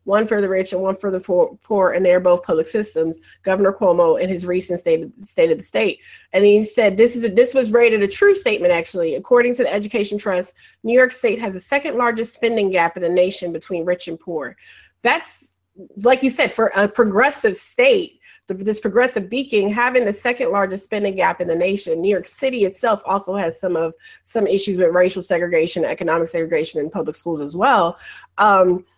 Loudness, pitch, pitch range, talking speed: -18 LUFS, 200 Hz, 180-240 Hz, 210 wpm